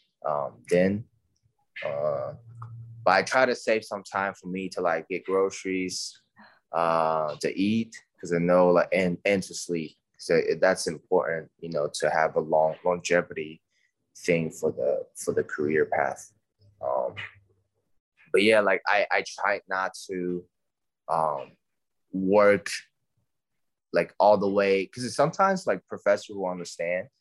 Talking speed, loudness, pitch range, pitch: 145 wpm, -26 LUFS, 90-120 Hz, 100 Hz